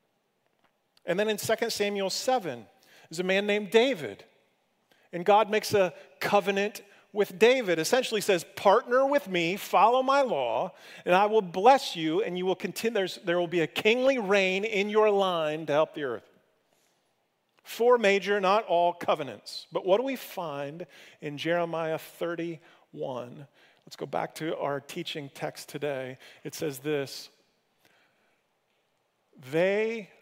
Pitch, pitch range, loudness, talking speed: 190 Hz, 165-215 Hz, -27 LUFS, 145 wpm